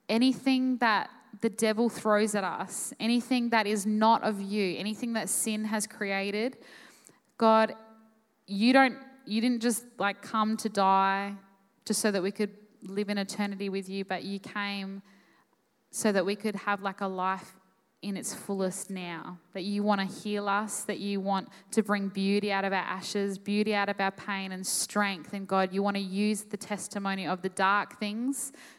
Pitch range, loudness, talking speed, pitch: 195-220 Hz, -29 LUFS, 185 wpm, 205 Hz